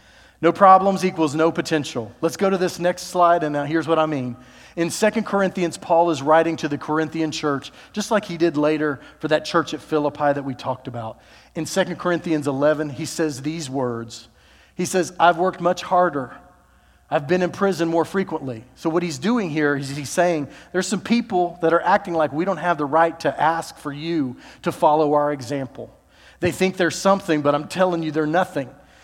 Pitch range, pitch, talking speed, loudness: 145-180 Hz, 160 Hz, 205 wpm, -21 LUFS